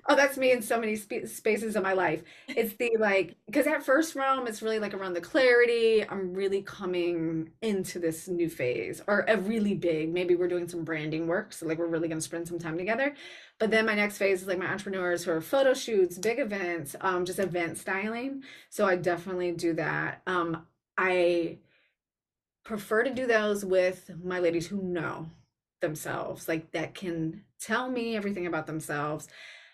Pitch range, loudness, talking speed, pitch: 170-220 Hz, -29 LUFS, 190 wpm, 190 Hz